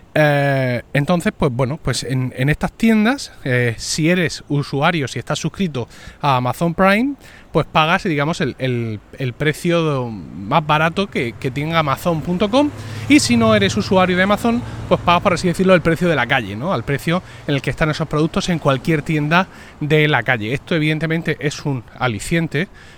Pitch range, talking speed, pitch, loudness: 135-180 Hz, 180 wpm, 155 Hz, -18 LUFS